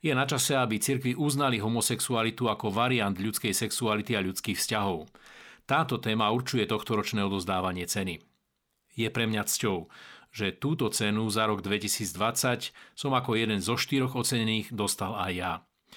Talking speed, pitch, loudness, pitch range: 145 wpm, 110 Hz, -28 LUFS, 105-125 Hz